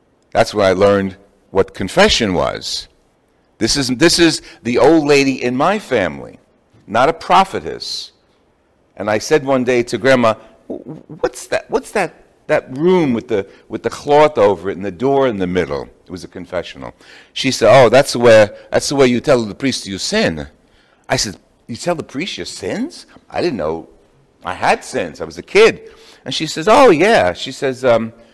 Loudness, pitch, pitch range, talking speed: -15 LUFS, 130 Hz, 110-155 Hz, 195 wpm